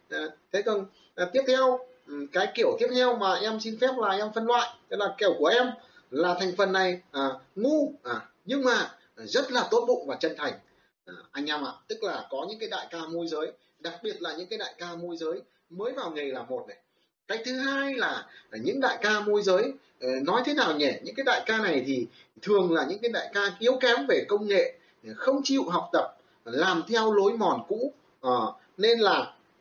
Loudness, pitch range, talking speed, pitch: -27 LUFS, 185-270 Hz, 220 wpm, 225 Hz